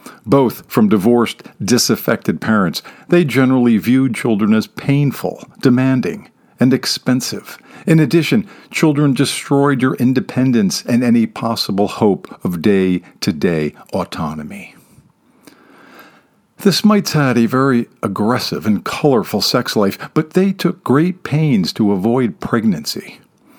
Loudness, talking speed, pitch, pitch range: -15 LUFS, 120 wpm, 130 Hz, 115-155 Hz